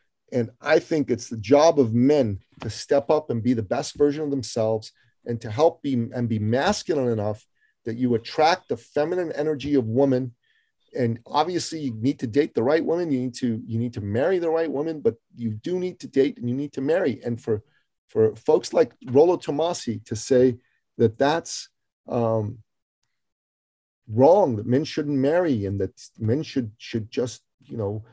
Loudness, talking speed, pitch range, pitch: -24 LUFS, 190 wpm, 115-145 Hz, 125 Hz